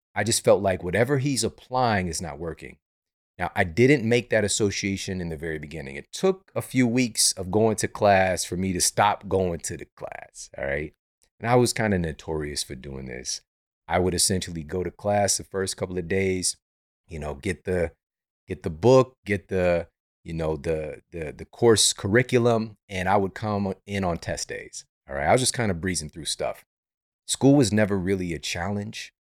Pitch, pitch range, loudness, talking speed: 95 Hz, 85-110 Hz, -24 LUFS, 205 wpm